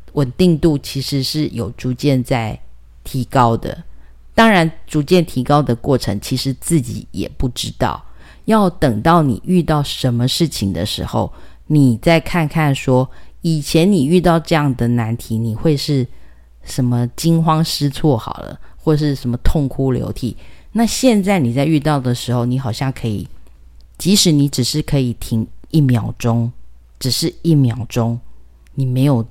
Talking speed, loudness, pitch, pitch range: 225 characters per minute, -16 LUFS, 130 Hz, 115-155 Hz